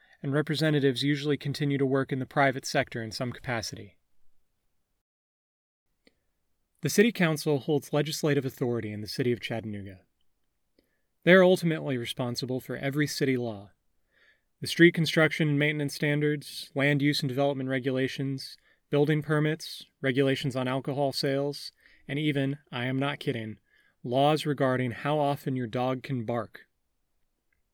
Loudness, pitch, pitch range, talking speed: -28 LUFS, 140 Hz, 125-145 Hz, 135 wpm